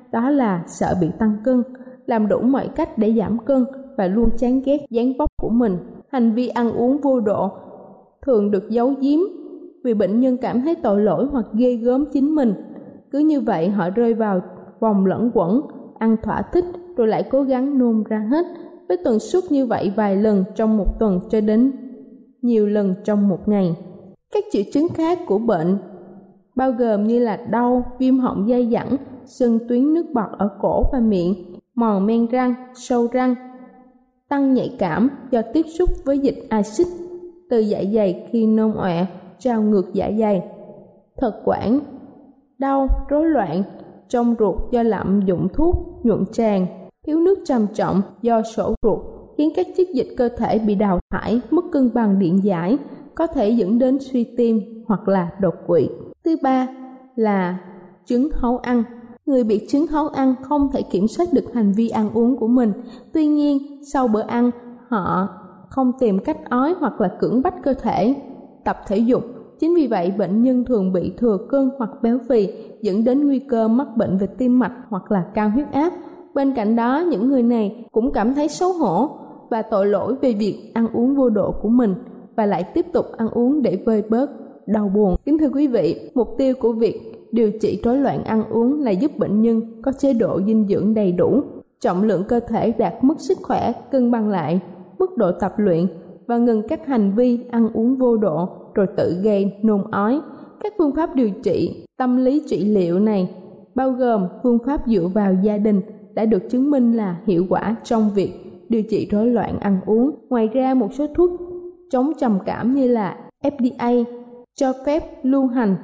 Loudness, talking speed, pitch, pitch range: -19 LUFS, 195 wpm, 235 Hz, 210-265 Hz